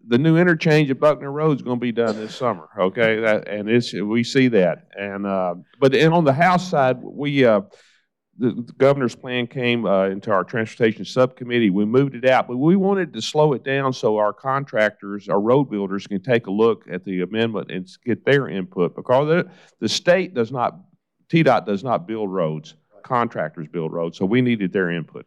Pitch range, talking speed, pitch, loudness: 100-135 Hz, 205 wpm, 120 Hz, -20 LUFS